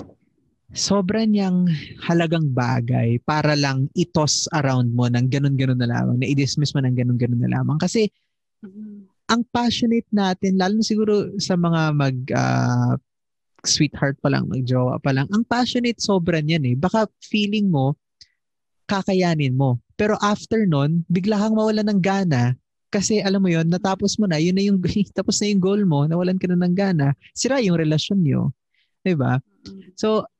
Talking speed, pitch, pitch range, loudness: 160 wpm, 175 Hz, 135-200 Hz, -20 LUFS